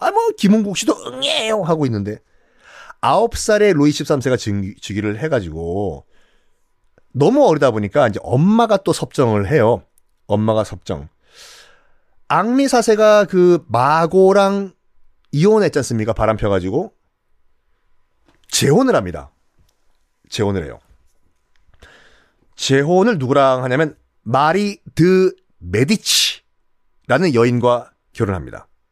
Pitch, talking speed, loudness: 130 Hz, 230 characters per minute, -16 LUFS